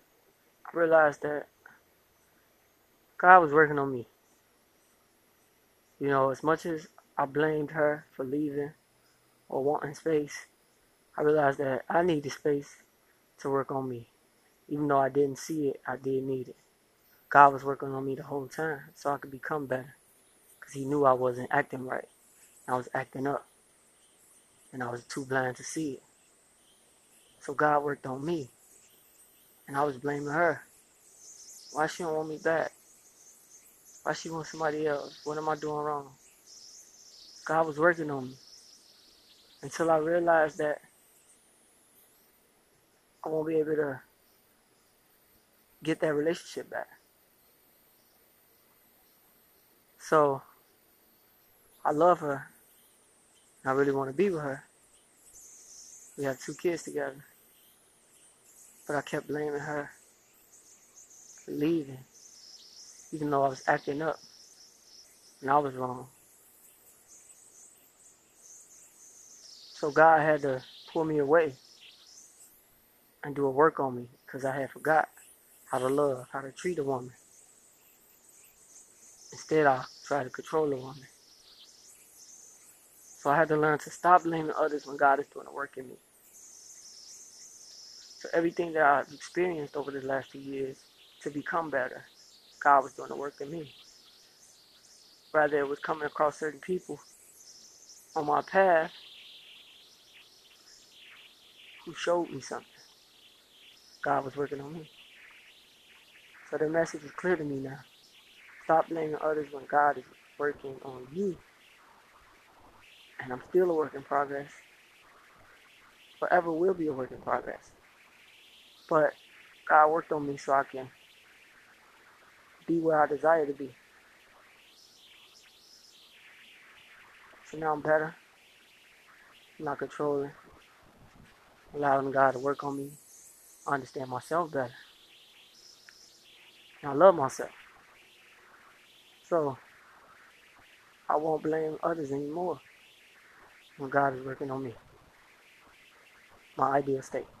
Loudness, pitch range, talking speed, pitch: -29 LUFS, 135-155 Hz, 130 wpm, 145 Hz